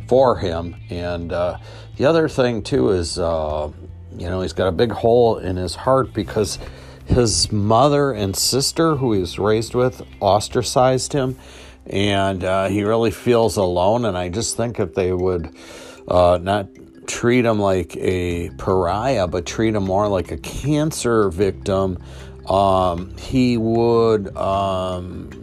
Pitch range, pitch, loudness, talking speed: 90-115 Hz, 100 Hz, -19 LUFS, 150 wpm